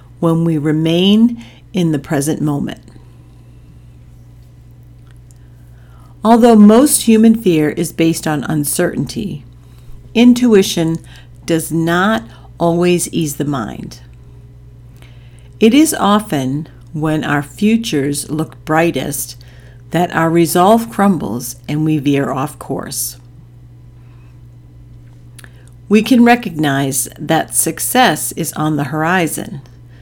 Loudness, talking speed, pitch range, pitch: -14 LUFS, 95 wpm, 120-165 Hz, 145 Hz